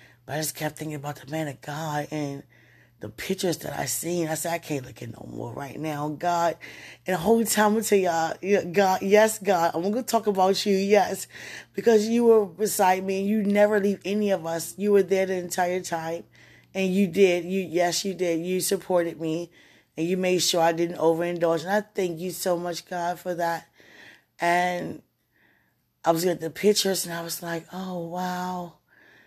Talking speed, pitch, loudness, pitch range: 205 wpm, 180 Hz, -25 LUFS, 165-195 Hz